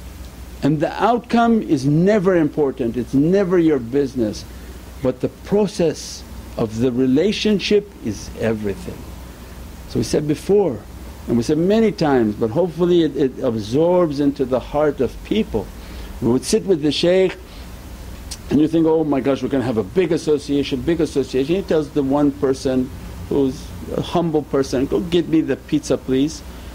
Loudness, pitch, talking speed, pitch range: -19 LUFS, 145 Hz, 165 wpm, 130-170 Hz